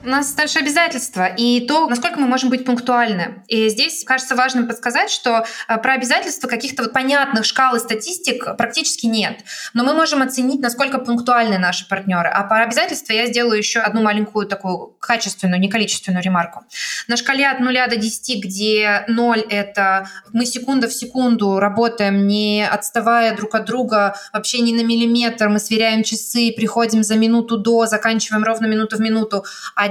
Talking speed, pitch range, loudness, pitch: 170 wpm, 215-255 Hz, -17 LUFS, 230 Hz